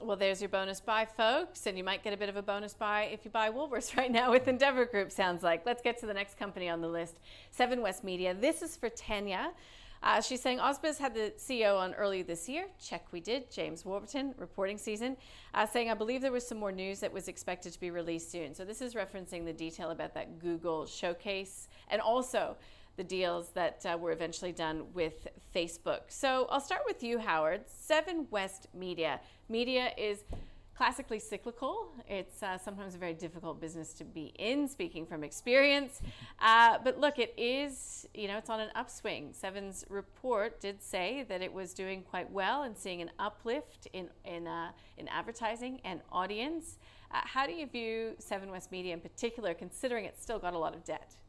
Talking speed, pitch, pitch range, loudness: 205 wpm, 205 Hz, 180-245 Hz, -35 LUFS